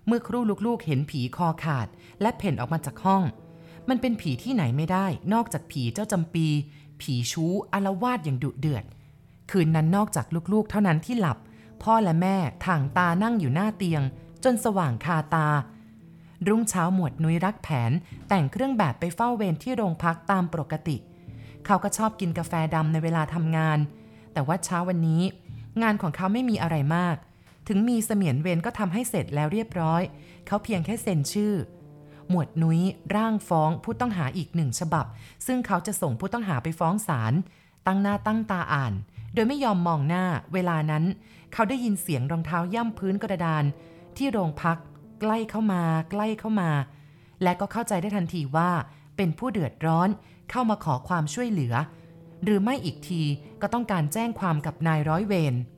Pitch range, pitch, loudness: 155-205 Hz, 170 Hz, -26 LUFS